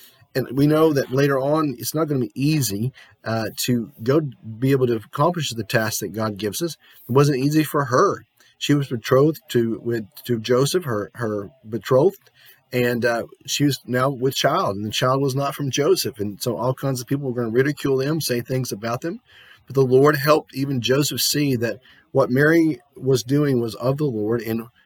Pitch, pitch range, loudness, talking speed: 130 Hz, 120-145 Hz, -21 LUFS, 210 wpm